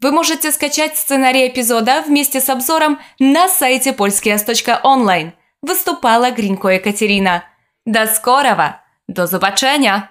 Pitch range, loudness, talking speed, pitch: 210-285 Hz, -13 LUFS, 105 wpm, 255 Hz